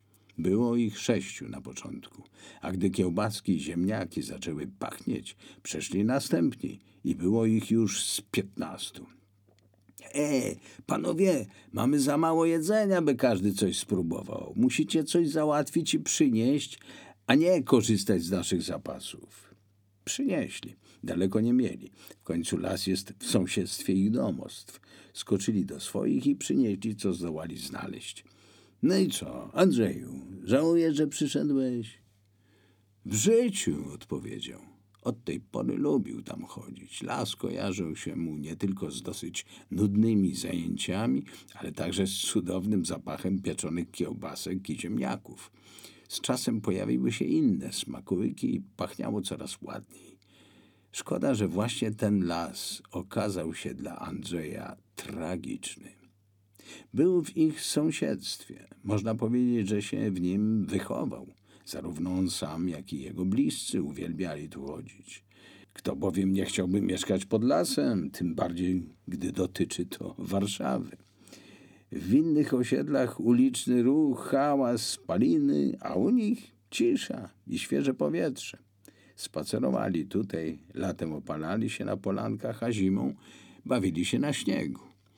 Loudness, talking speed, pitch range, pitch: -30 LUFS, 125 wpm, 95-130 Hz, 105 Hz